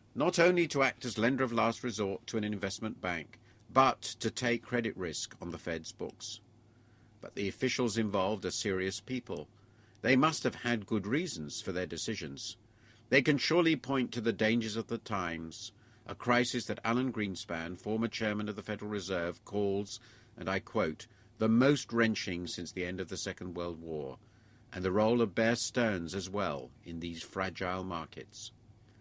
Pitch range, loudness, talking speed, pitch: 95-115 Hz, -33 LUFS, 180 wpm, 110 Hz